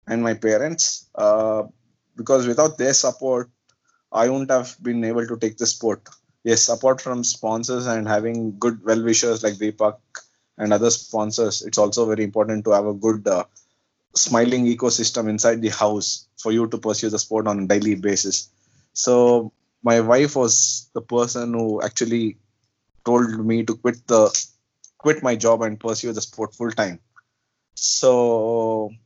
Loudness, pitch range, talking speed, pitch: -20 LUFS, 110-120 Hz, 160 wpm, 115 Hz